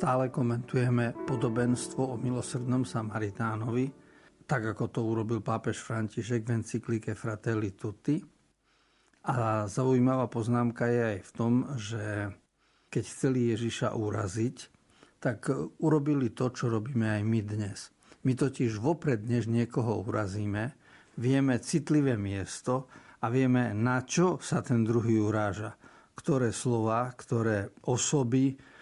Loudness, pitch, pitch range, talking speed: -30 LUFS, 120 Hz, 110-130 Hz, 120 wpm